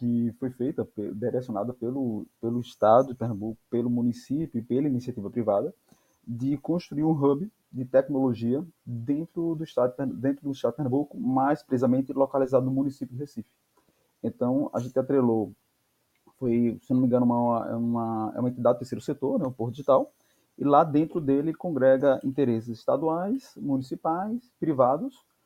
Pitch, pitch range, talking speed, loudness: 130 Hz, 120-145 Hz, 160 wpm, -27 LUFS